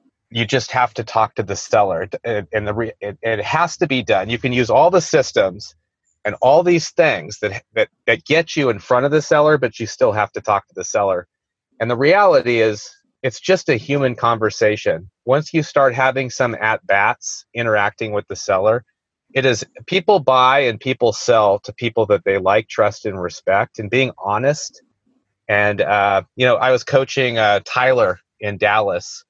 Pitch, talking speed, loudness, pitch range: 125 Hz, 195 wpm, -17 LUFS, 110-145 Hz